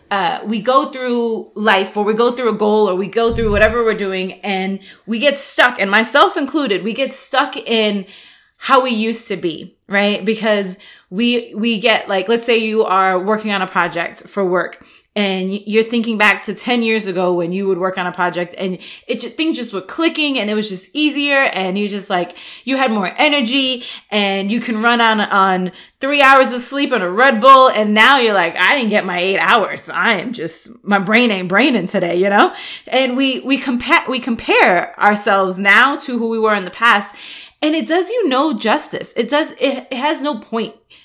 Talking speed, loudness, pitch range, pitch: 215 wpm, -15 LUFS, 195-265 Hz, 225 Hz